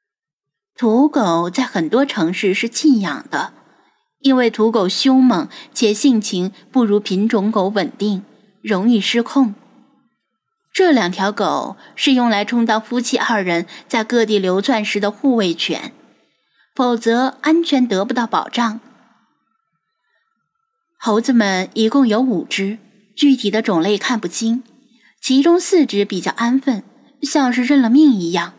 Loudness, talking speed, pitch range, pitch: -16 LUFS, 195 characters per minute, 205-265 Hz, 235 Hz